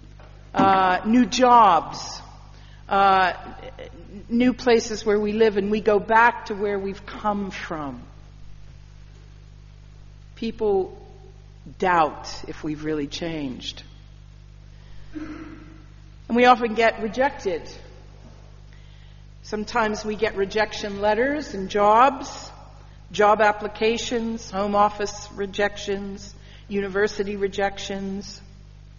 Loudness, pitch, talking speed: -22 LUFS, 200 Hz, 90 wpm